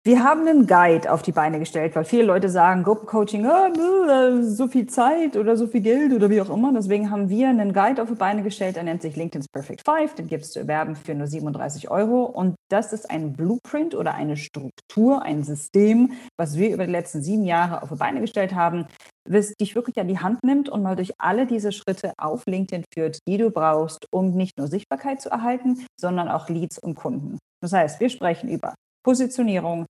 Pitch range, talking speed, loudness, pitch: 170-240 Hz, 215 wpm, -22 LUFS, 200 Hz